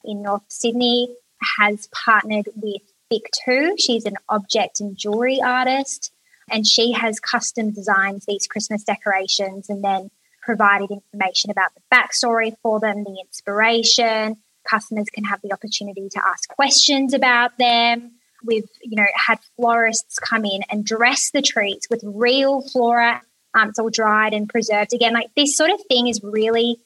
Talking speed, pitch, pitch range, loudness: 155 wpm, 225 Hz, 205-240 Hz, -18 LUFS